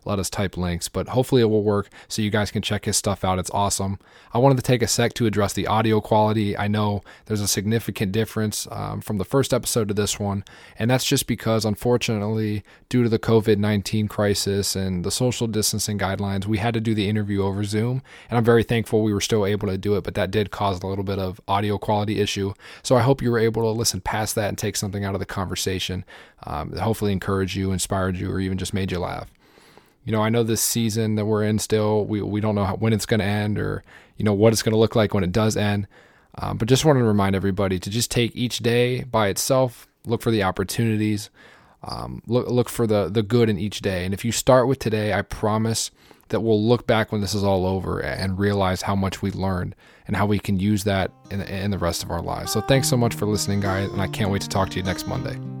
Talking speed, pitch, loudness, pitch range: 255 wpm, 105 Hz, -22 LUFS, 100-115 Hz